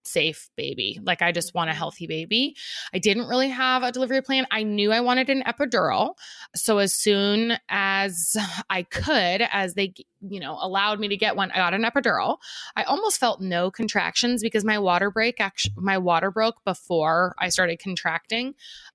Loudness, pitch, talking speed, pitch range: -23 LUFS, 200 Hz, 180 wpm, 185-230 Hz